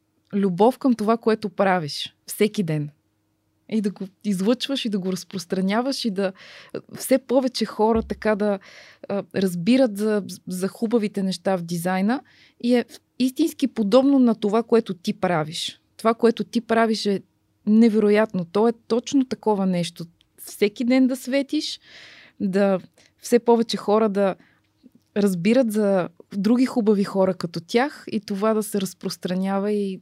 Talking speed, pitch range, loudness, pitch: 140 wpm, 195-235 Hz, -22 LUFS, 210 Hz